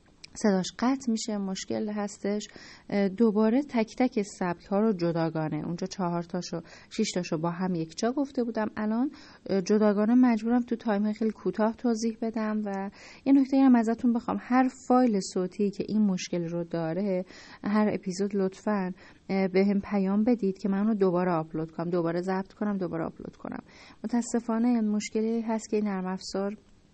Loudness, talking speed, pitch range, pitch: -28 LUFS, 160 wpm, 185-225 Hz, 205 Hz